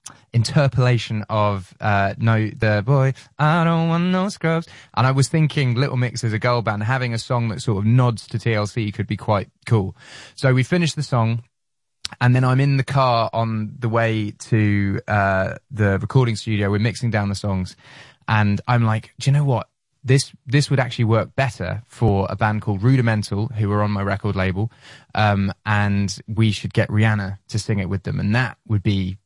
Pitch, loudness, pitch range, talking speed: 115 Hz, -20 LUFS, 105-130 Hz, 200 wpm